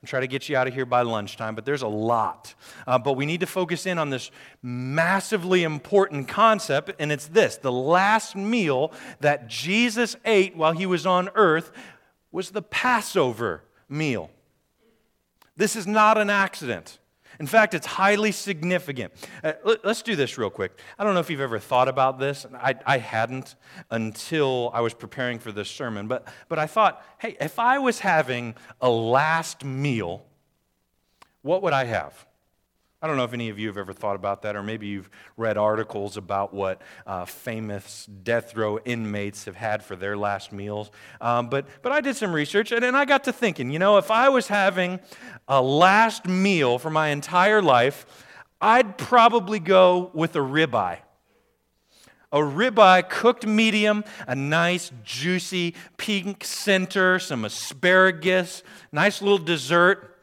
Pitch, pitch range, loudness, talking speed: 150 Hz, 115-195 Hz, -23 LUFS, 170 wpm